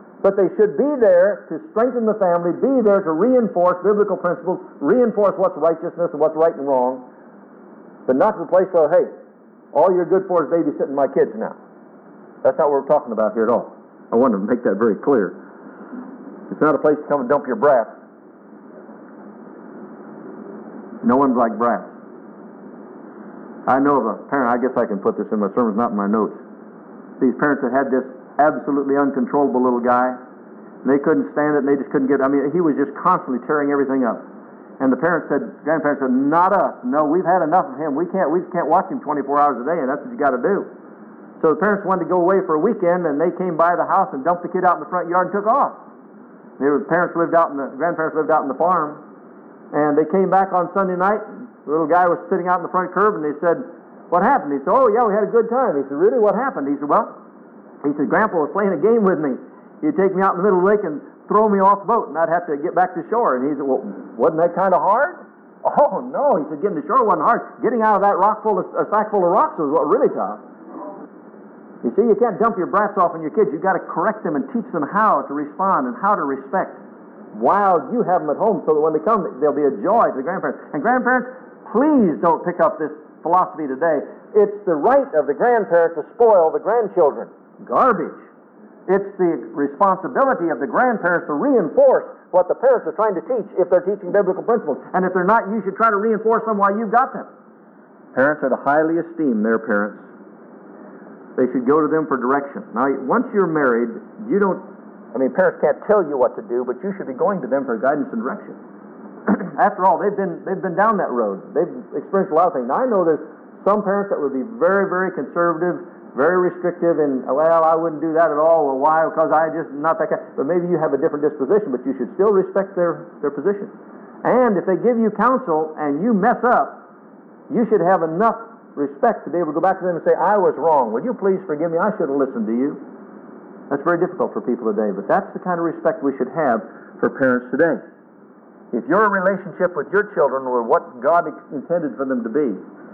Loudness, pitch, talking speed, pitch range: -19 LUFS, 175 Hz, 235 wpm, 150-205 Hz